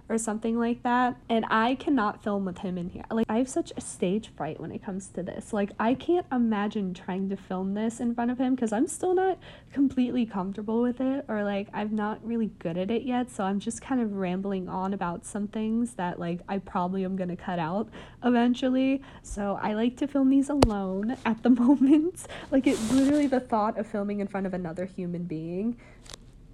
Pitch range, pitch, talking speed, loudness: 190-245 Hz, 215 Hz, 215 wpm, -28 LUFS